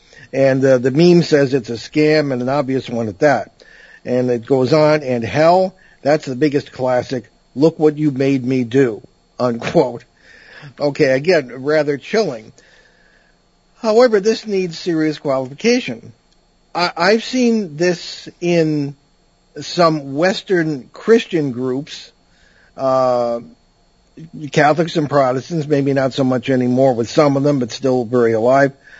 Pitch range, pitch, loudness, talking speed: 130-165 Hz, 145 Hz, -16 LUFS, 135 wpm